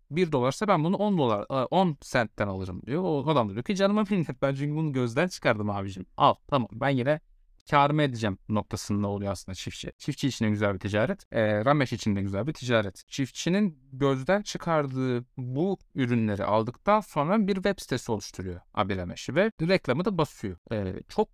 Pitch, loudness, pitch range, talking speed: 130 Hz, -27 LUFS, 105-165 Hz, 175 wpm